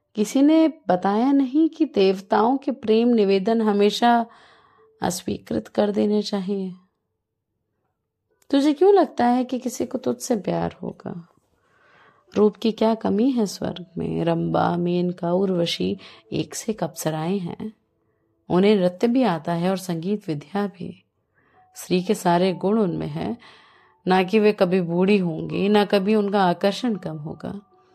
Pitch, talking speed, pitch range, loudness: 200 Hz, 140 wpm, 175-230 Hz, -22 LUFS